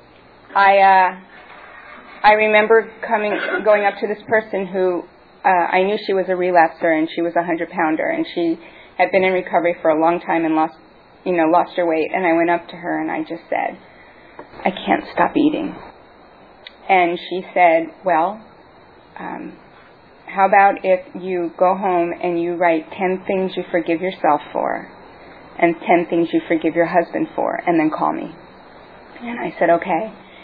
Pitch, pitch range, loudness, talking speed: 180 Hz, 170-205 Hz, -18 LUFS, 180 wpm